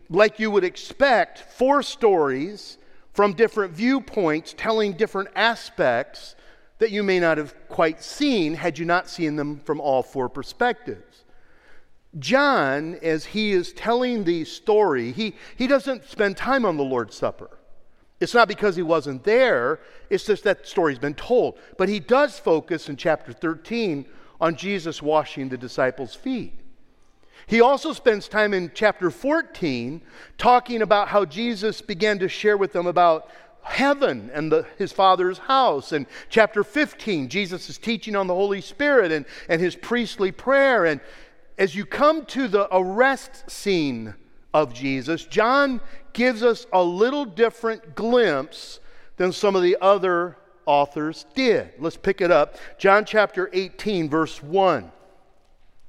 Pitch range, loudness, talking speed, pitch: 160-235 Hz, -22 LUFS, 150 wpm, 200 Hz